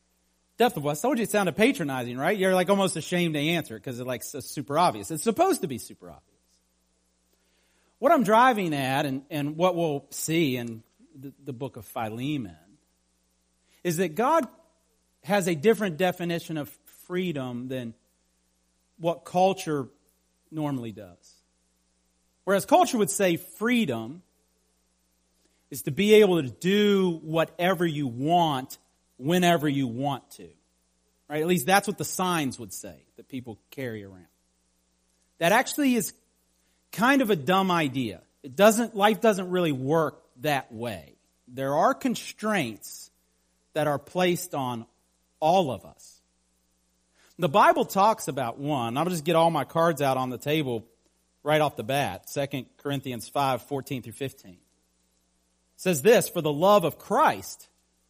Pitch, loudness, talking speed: 140 Hz, -25 LUFS, 150 wpm